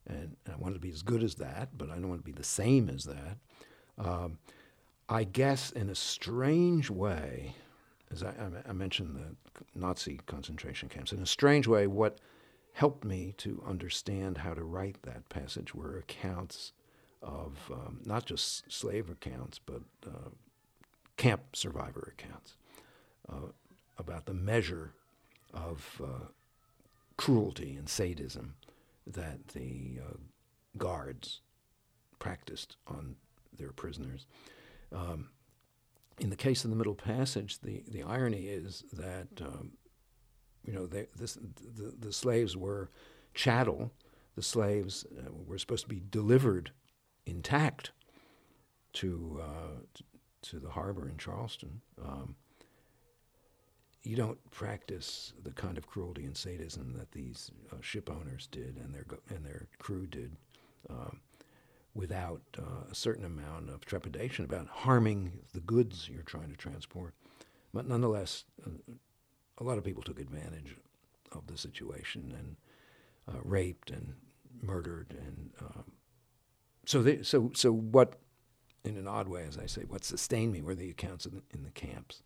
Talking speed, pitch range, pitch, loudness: 145 wpm, 85-120 Hz, 100 Hz, -36 LUFS